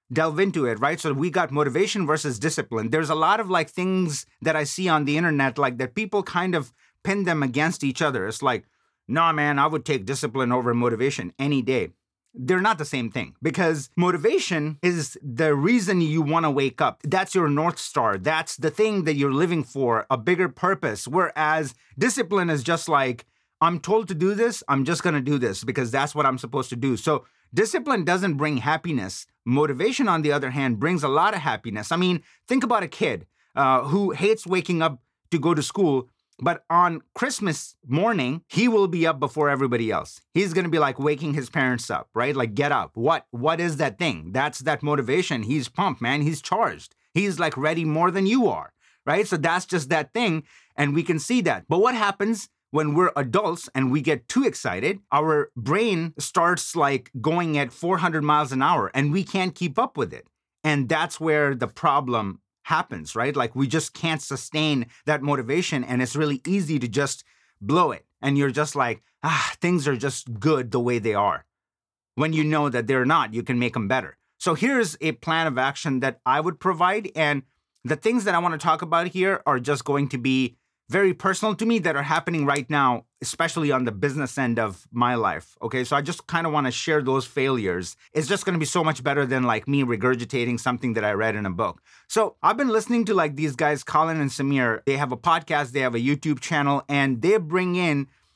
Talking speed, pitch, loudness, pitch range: 215 wpm, 150 Hz, -23 LUFS, 135-175 Hz